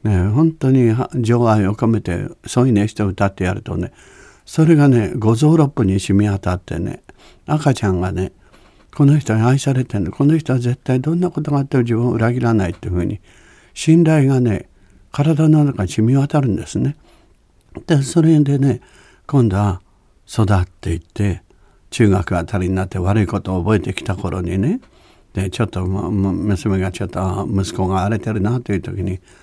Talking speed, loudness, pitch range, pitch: 330 characters per minute, -17 LUFS, 95-130 Hz, 110 Hz